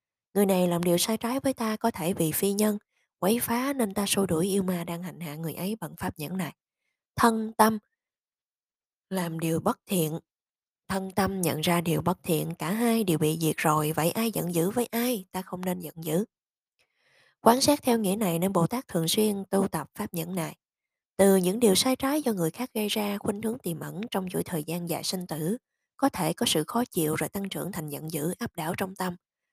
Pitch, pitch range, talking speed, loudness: 185 Hz, 165-220 Hz, 230 wpm, -27 LUFS